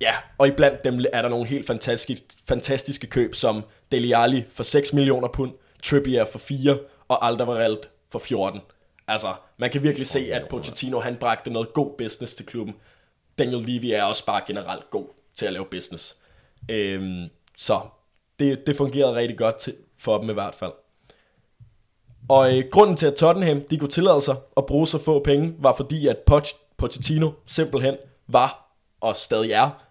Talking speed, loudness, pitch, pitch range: 170 wpm, -22 LUFS, 135 Hz, 115-140 Hz